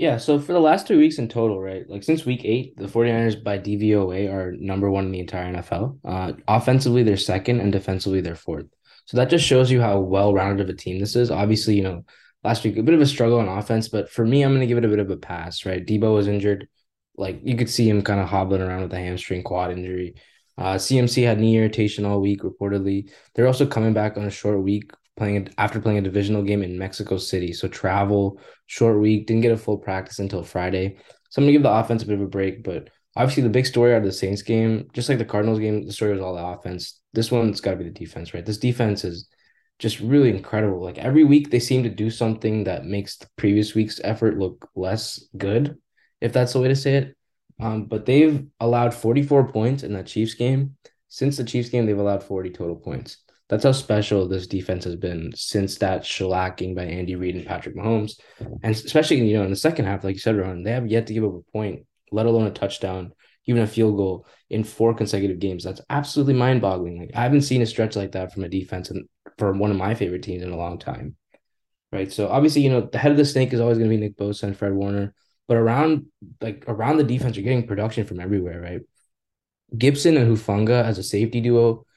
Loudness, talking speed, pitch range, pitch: -22 LUFS, 240 wpm, 95-120 Hz, 105 Hz